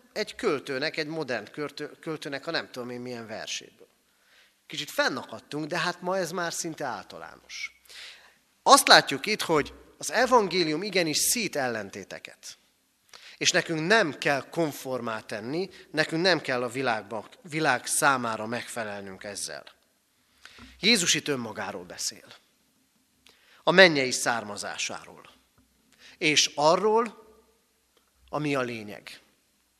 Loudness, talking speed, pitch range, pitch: -26 LUFS, 115 wpm, 125-185 Hz, 155 Hz